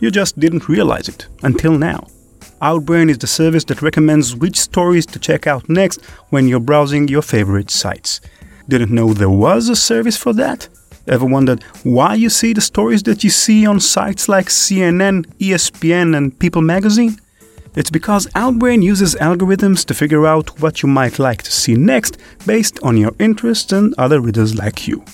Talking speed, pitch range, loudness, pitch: 180 wpm, 135-200 Hz, -13 LUFS, 160 Hz